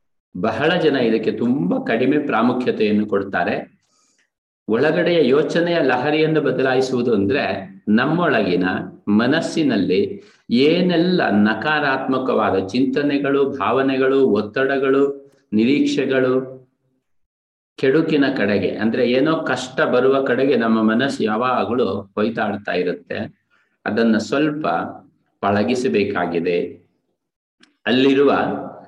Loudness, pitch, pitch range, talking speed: -18 LUFS, 130 Hz, 110-140 Hz, 75 wpm